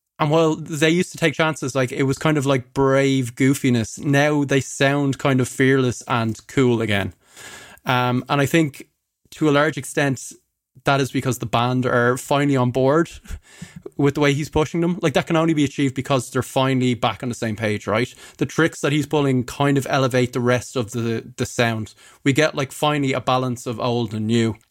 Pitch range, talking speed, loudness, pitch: 125-145 Hz, 210 wpm, -20 LUFS, 135 Hz